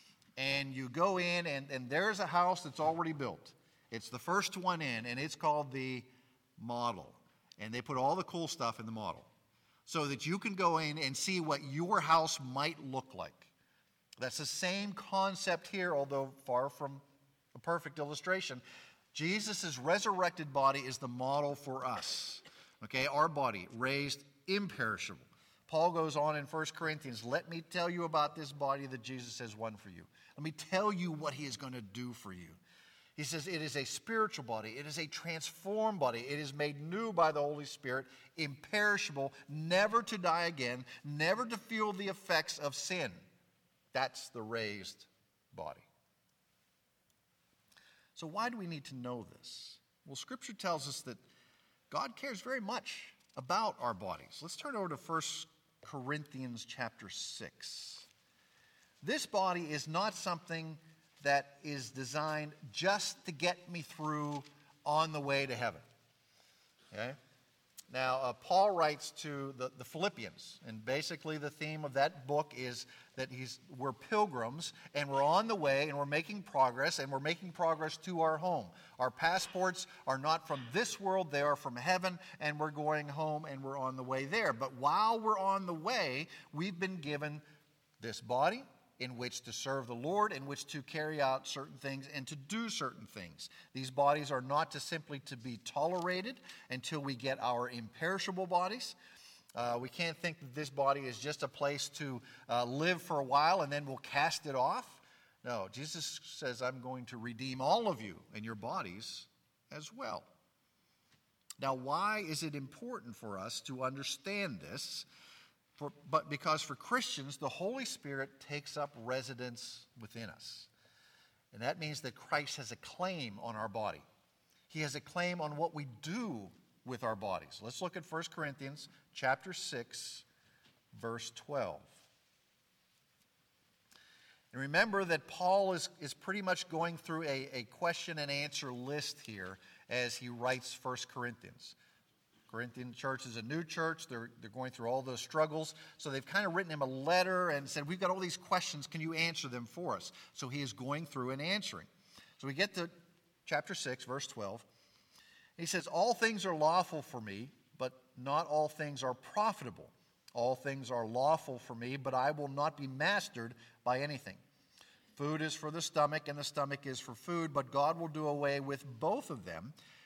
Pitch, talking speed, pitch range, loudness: 145 Hz, 175 wpm, 130-170 Hz, -37 LUFS